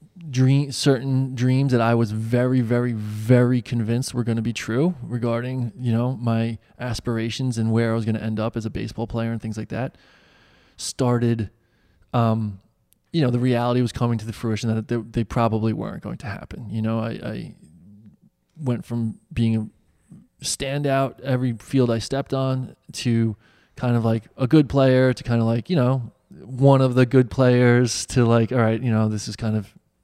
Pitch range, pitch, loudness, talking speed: 115-130 Hz, 120 Hz, -22 LUFS, 195 wpm